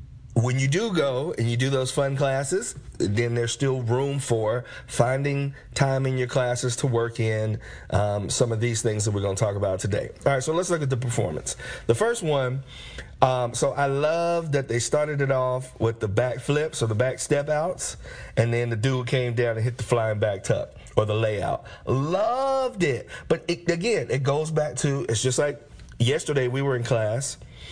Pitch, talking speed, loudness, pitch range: 130 Hz, 210 wpm, -25 LUFS, 115-140 Hz